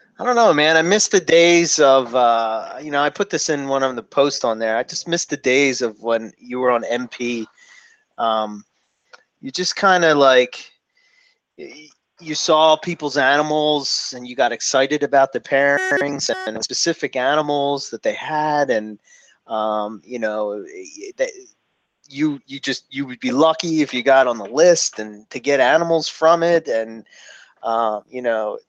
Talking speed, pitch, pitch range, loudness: 175 wpm, 145 Hz, 120-170 Hz, -18 LUFS